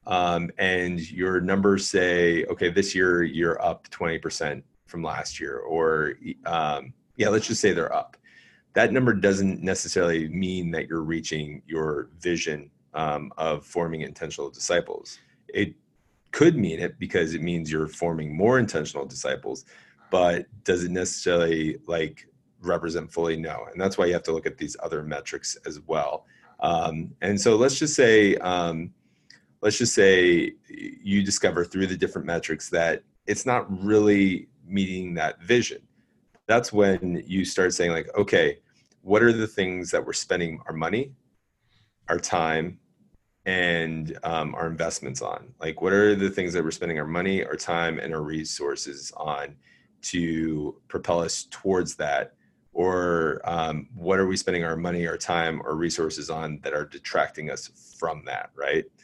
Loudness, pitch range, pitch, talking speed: -25 LUFS, 80-100 Hz, 90 Hz, 160 wpm